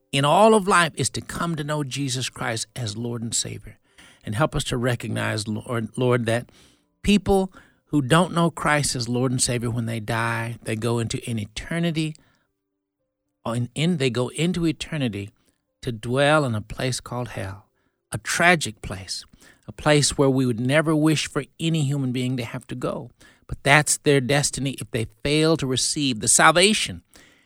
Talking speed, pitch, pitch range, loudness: 180 wpm, 130 Hz, 115-150 Hz, -22 LUFS